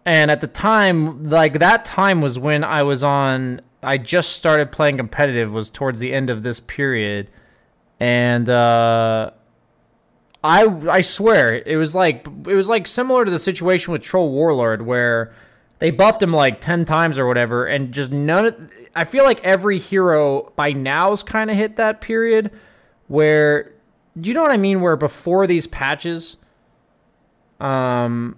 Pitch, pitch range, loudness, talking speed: 155 Hz, 130-190 Hz, -17 LUFS, 165 wpm